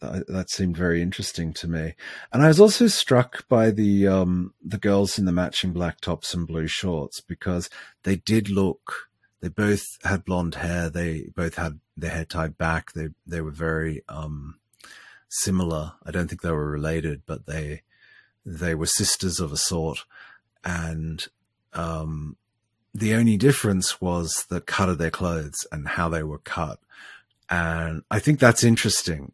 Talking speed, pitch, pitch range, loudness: 165 wpm, 85 Hz, 80-95 Hz, -24 LUFS